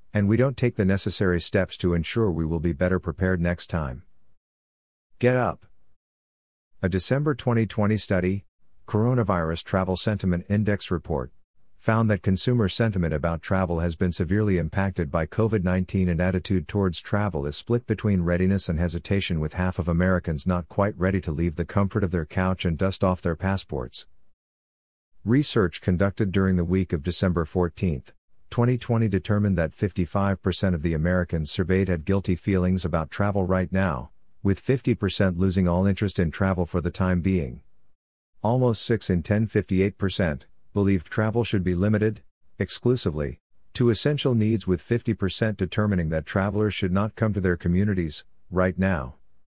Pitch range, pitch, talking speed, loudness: 85-105 Hz, 95 Hz, 155 wpm, -25 LUFS